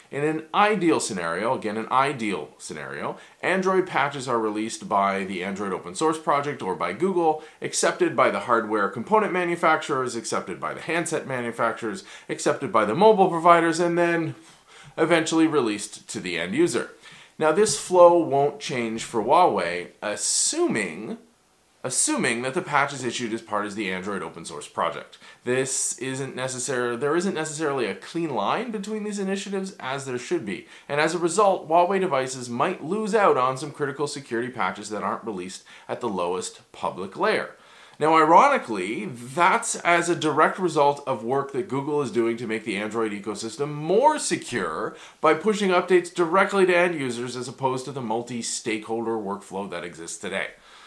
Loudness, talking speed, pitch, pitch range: -24 LUFS, 165 wpm, 145 Hz, 115-175 Hz